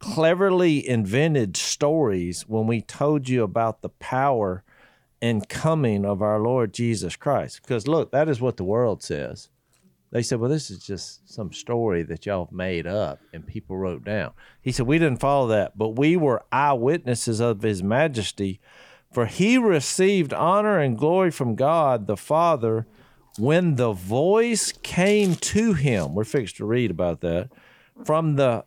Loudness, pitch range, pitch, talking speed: -23 LUFS, 105-155 Hz, 120 Hz, 165 wpm